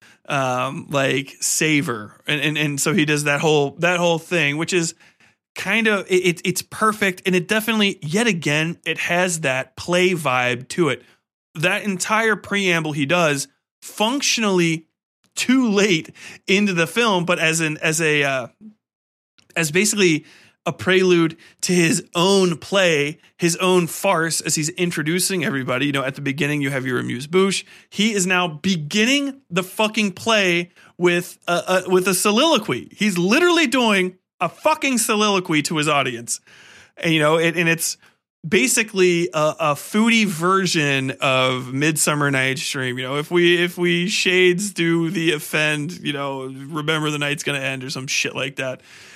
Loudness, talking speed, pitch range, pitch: -19 LUFS, 165 wpm, 150-190 Hz, 170 Hz